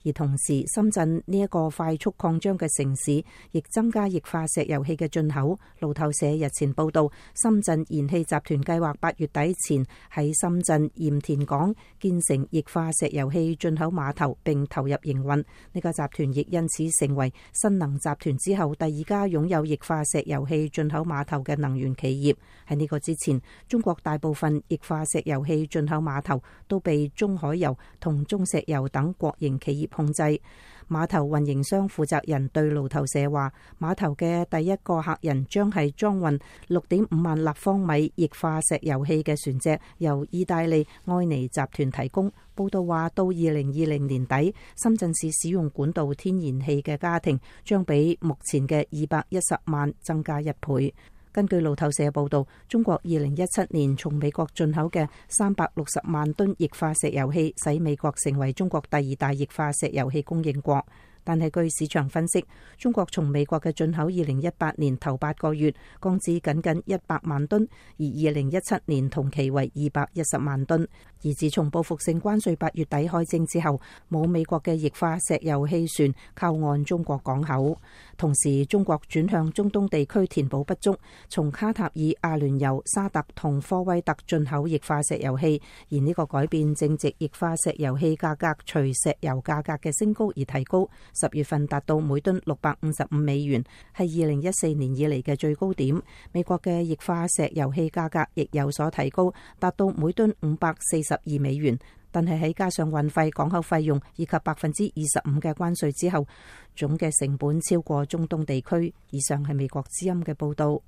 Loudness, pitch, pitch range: -26 LUFS, 155 Hz, 145-170 Hz